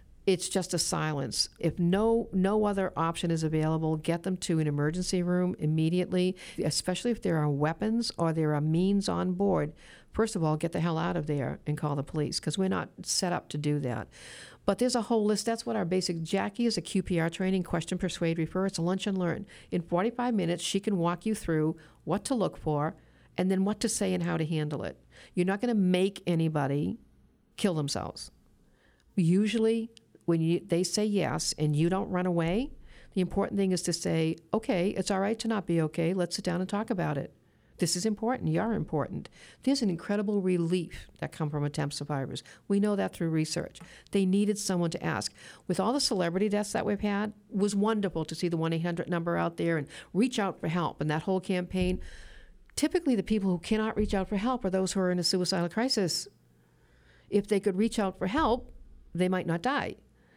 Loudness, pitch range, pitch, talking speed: -30 LUFS, 165-205 Hz, 180 Hz, 215 wpm